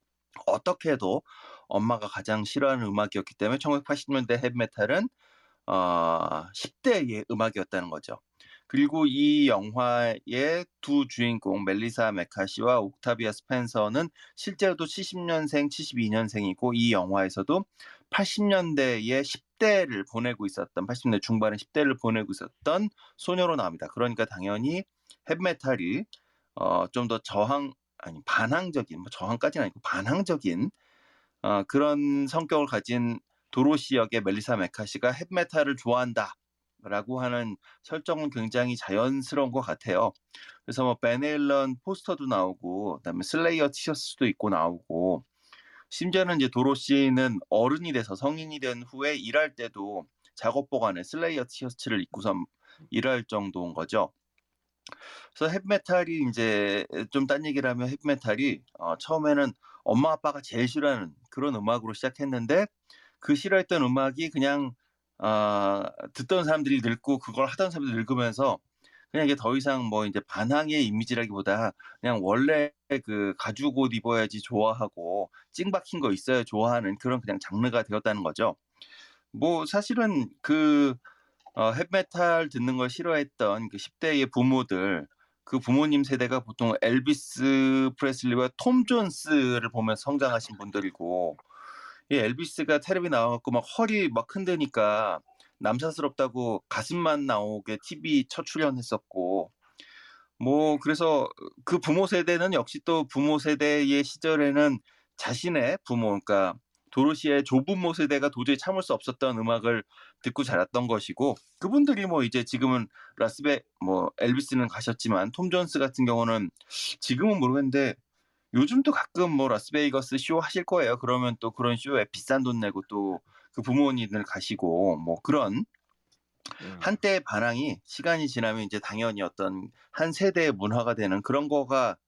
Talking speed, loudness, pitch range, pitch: 310 characters per minute, -28 LUFS, 115-155 Hz, 130 Hz